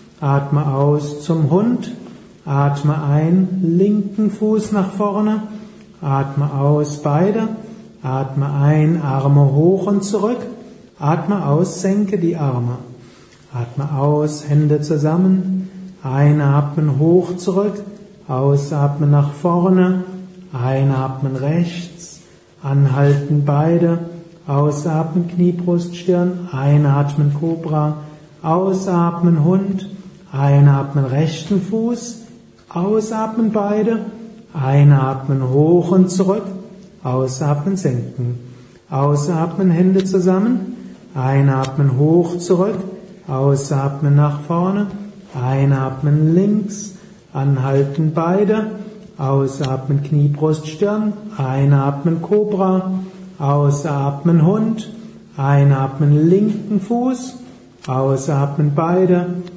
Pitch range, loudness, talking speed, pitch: 145-195 Hz, -17 LUFS, 85 wpm, 170 Hz